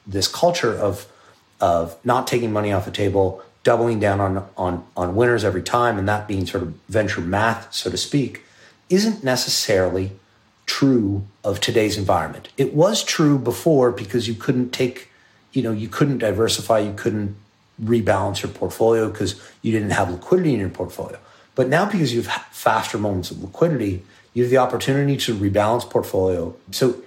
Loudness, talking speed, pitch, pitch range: -21 LUFS, 170 wpm, 110 Hz, 100-125 Hz